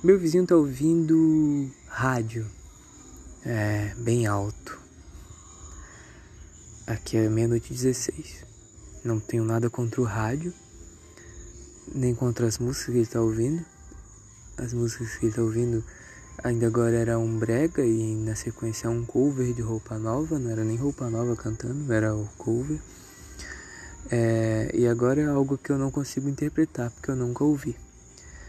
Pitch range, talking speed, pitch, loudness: 105-125 Hz, 145 wpm, 115 Hz, -26 LUFS